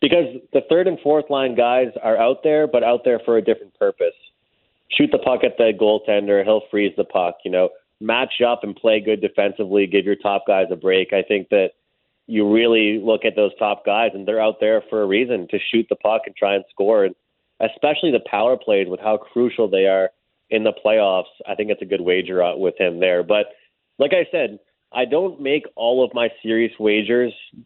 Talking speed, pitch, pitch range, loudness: 220 wpm, 110 Hz, 100-135 Hz, -19 LUFS